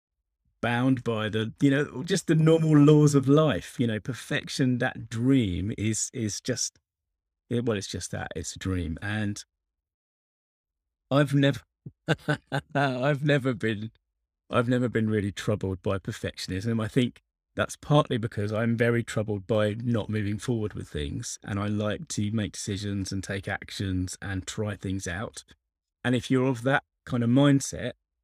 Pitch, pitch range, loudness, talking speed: 110 Hz, 95-130 Hz, -27 LUFS, 155 wpm